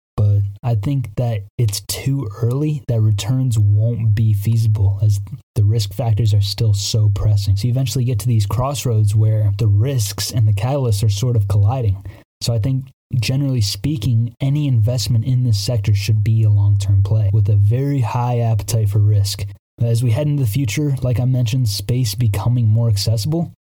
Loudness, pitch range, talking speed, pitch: -18 LUFS, 105-125 Hz, 185 wpm, 115 Hz